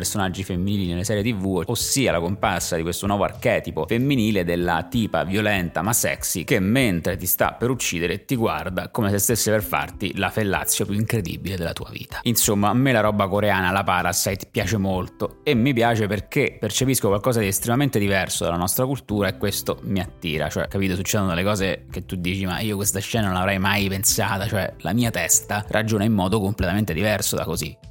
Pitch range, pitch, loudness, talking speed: 90-110 Hz, 100 Hz, -22 LUFS, 195 wpm